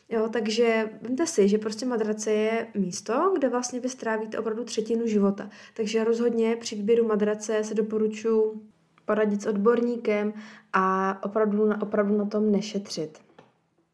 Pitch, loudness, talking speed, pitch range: 220 Hz, -26 LUFS, 140 wpm, 210-230 Hz